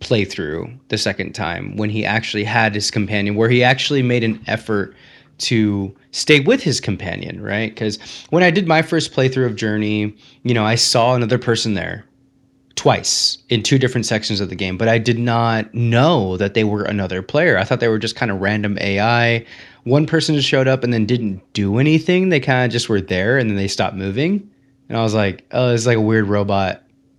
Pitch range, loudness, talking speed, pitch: 105-130 Hz, -17 LUFS, 210 wpm, 115 Hz